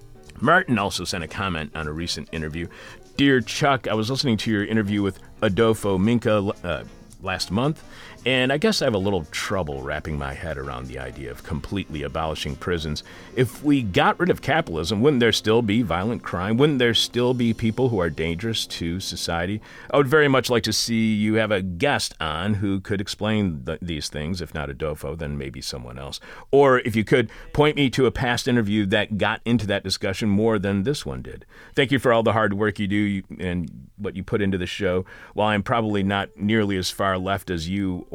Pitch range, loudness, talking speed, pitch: 85-115 Hz, -23 LUFS, 210 wpm, 100 Hz